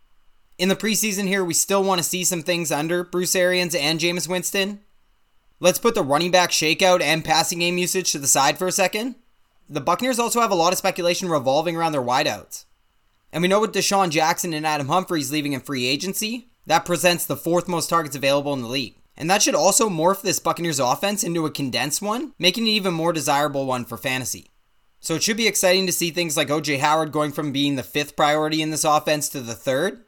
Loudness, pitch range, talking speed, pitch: -21 LUFS, 150-185 Hz, 220 wpm, 170 Hz